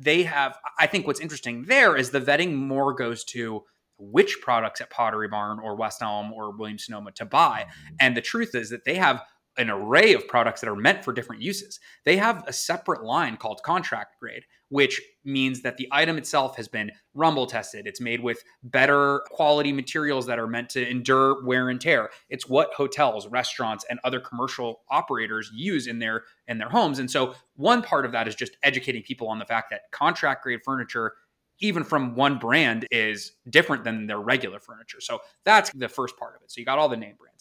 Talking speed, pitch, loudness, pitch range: 210 wpm, 130 Hz, -24 LUFS, 115-145 Hz